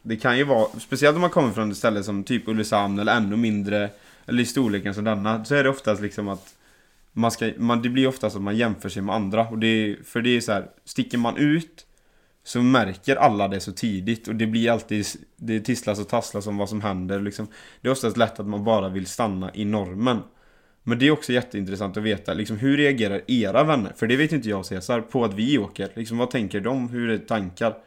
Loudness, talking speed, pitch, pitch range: -23 LUFS, 240 wpm, 110 Hz, 100-120 Hz